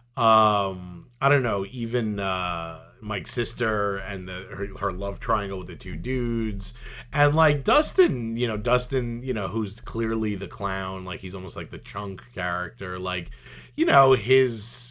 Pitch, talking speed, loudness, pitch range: 105 Hz, 165 wpm, -25 LUFS, 95-120 Hz